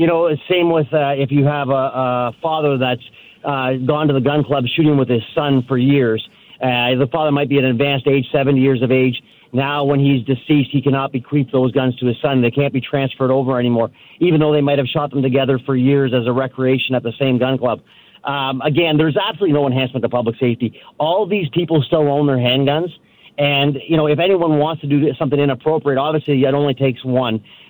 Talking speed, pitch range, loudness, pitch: 225 wpm, 130-145 Hz, -17 LUFS, 140 Hz